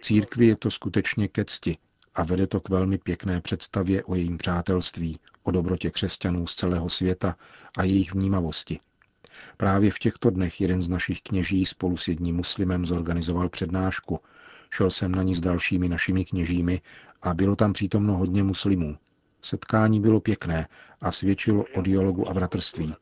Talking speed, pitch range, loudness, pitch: 160 wpm, 90-100 Hz, -25 LUFS, 95 Hz